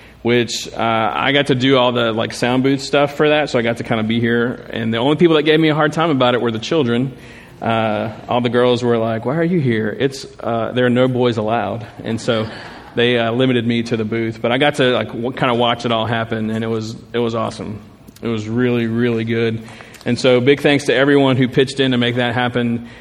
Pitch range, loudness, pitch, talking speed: 115-130 Hz, -17 LUFS, 120 Hz, 255 wpm